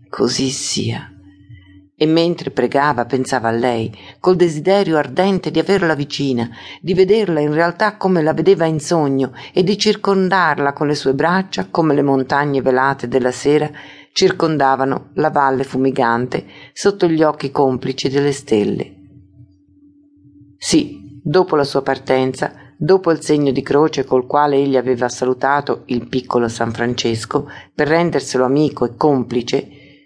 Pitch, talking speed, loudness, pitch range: 140 Hz, 140 wpm, -16 LUFS, 130-160 Hz